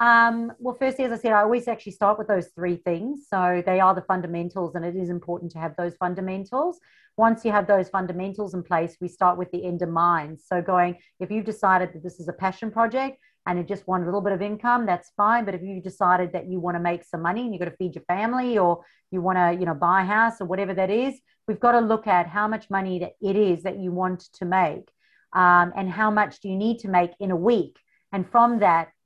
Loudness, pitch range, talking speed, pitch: -24 LUFS, 180-215 Hz, 255 wpm, 190 Hz